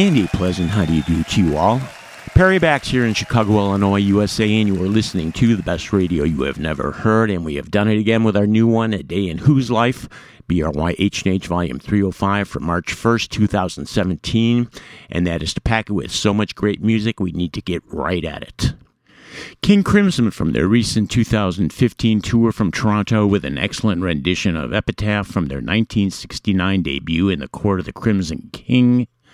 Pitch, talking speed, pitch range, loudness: 105 Hz, 190 wpm, 90-115 Hz, -18 LUFS